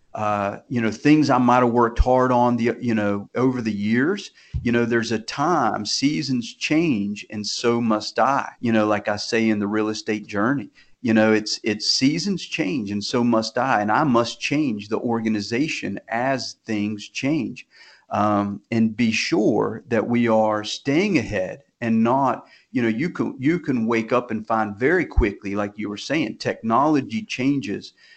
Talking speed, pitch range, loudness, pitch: 180 wpm, 105-125 Hz, -22 LUFS, 115 Hz